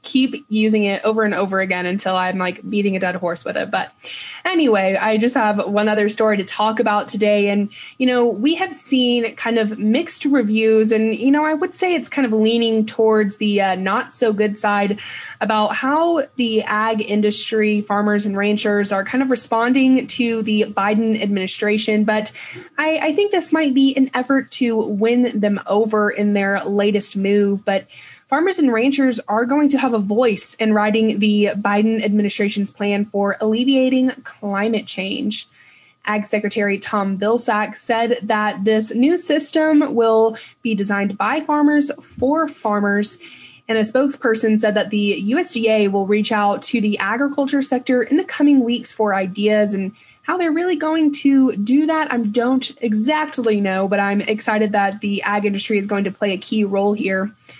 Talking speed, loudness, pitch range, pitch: 180 wpm, -18 LUFS, 205-260 Hz, 220 Hz